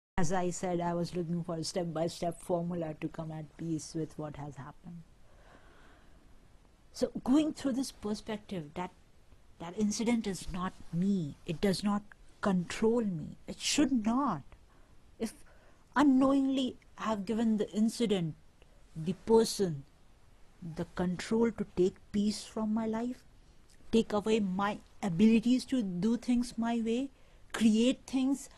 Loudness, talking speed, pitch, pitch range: -32 LUFS, 140 wpm, 205 Hz, 175-230 Hz